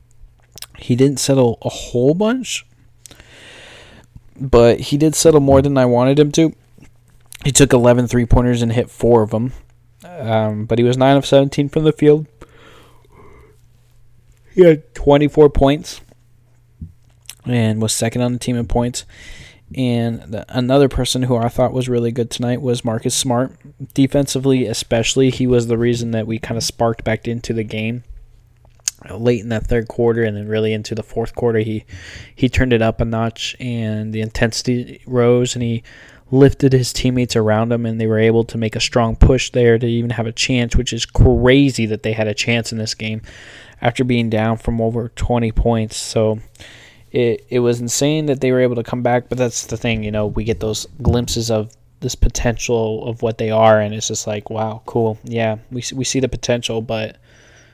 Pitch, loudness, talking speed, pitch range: 120 Hz, -17 LUFS, 190 wpm, 115-125 Hz